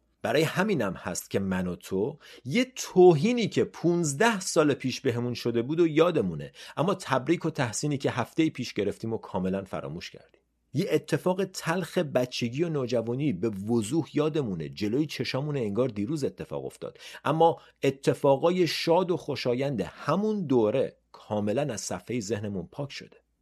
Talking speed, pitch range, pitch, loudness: 150 wpm, 120-165 Hz, 140 Hz, -27 LUFS